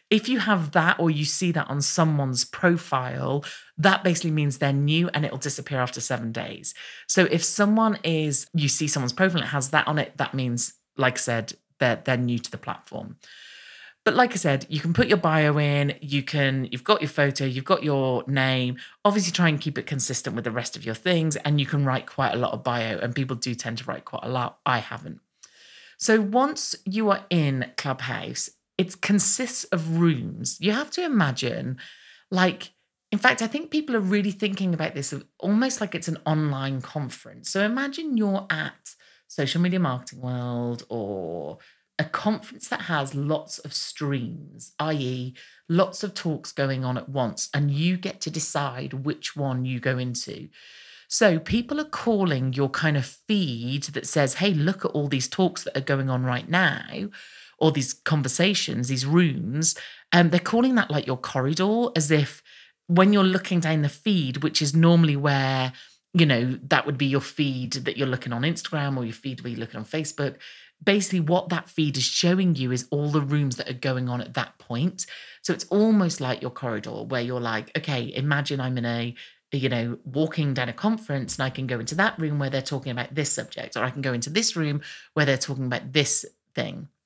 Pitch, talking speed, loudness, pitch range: 150 Hz, 205 wpm, -24 LUFS, 130-180 Hz